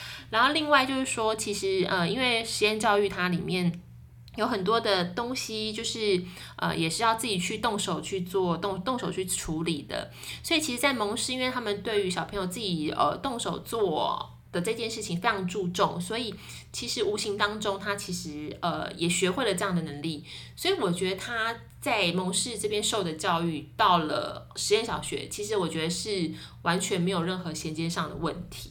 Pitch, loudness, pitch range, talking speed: 195 Hz, -28 LUFS, 170-220 Hz, 285 characters per minute